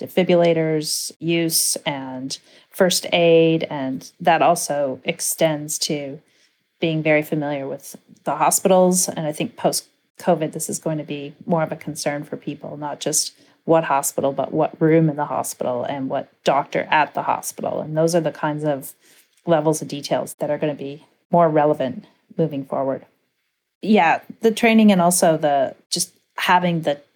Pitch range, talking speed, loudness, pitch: 145-175 Hz, 165 wpm, -20 LUFS, 160 Hz